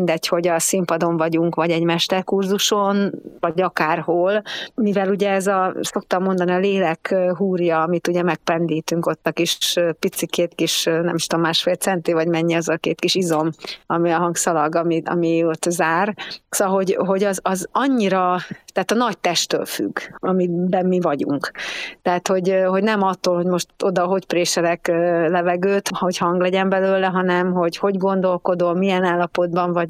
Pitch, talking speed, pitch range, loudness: 180 Hz, 165 wpm, 170-190 Hz, -19 LUFS